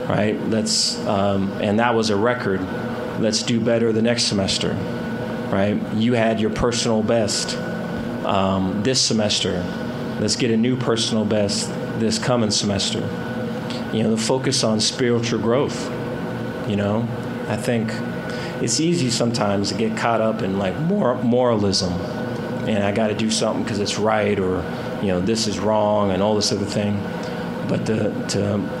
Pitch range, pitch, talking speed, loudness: 105-120 Hz, 110 Hz, 160 wpm, -21 LUFS